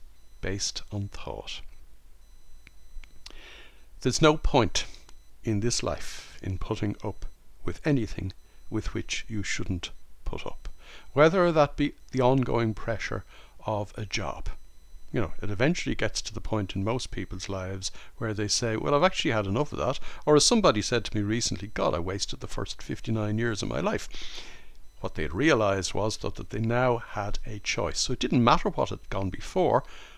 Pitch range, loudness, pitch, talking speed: 95-120 Hz, -28 LUFS, 105 Hz, 175 wpm